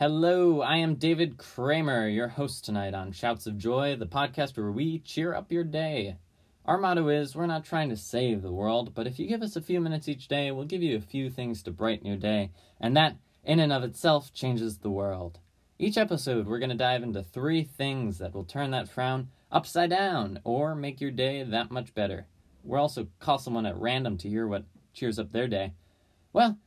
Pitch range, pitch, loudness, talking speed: 105-150 Hz, 125 Hz, -29 LUFS, 215 wpm